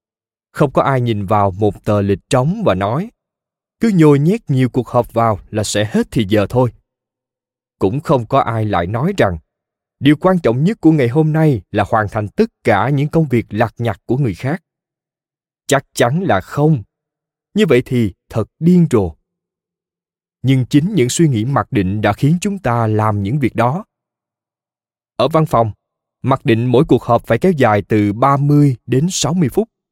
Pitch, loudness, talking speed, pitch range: 125 Hz, -15 LUFS, 185 wpm, 110-155 Hz